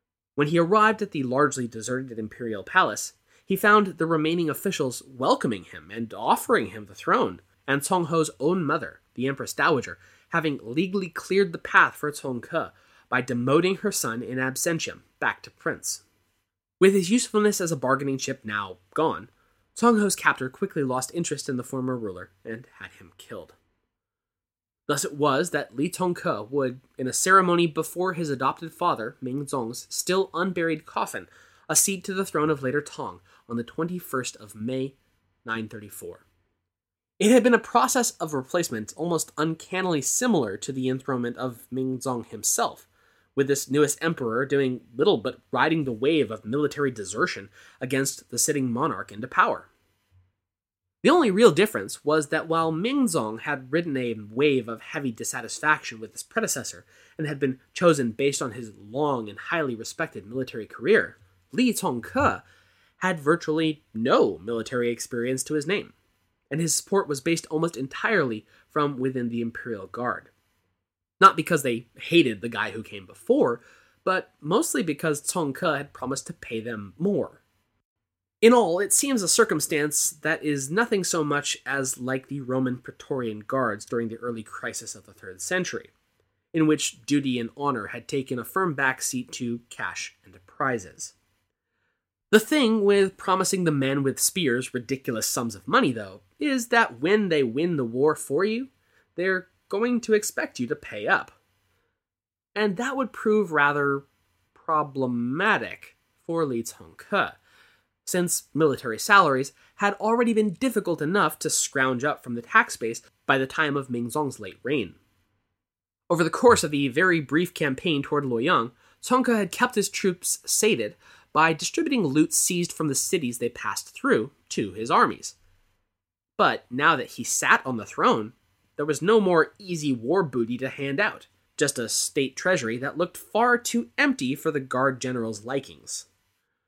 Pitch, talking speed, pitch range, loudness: 140 Hz, 165 wpm, 120-175 Hz, -25 LUFS